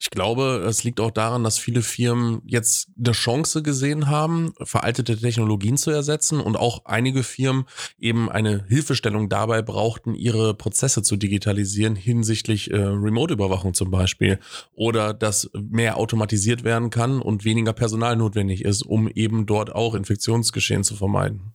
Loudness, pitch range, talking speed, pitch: -22 LUFS, 105-120 Hz, 150 wpm, 115 Hz